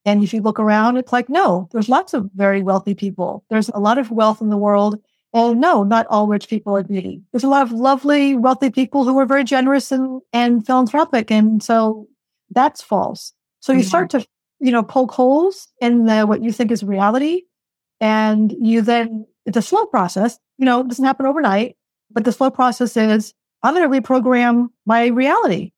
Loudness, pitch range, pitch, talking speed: -17 LUFS, 215-265 Hz, 235 Hz, 205 wpm